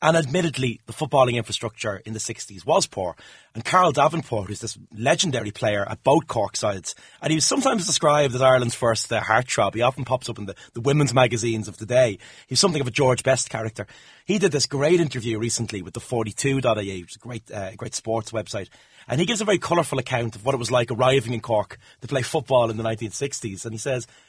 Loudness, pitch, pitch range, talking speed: -23 LUFS, 120 Hz, 115-140 Hz, 225 wpm